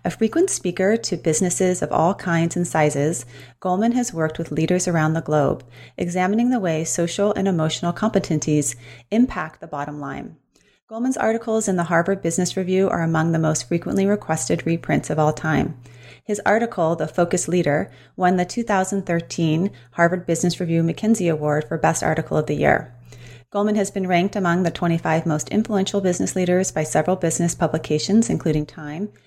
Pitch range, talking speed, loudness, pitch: 155-195 Hz, 170 wpm, -21 LUFS, 170 Hz